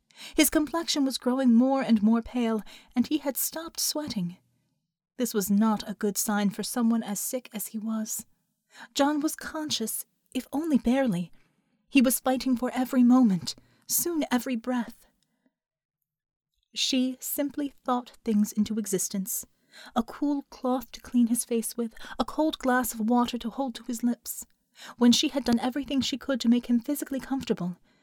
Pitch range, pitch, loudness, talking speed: 220-265 Hz, 245 Hz, -27 LUFS, 165 wpm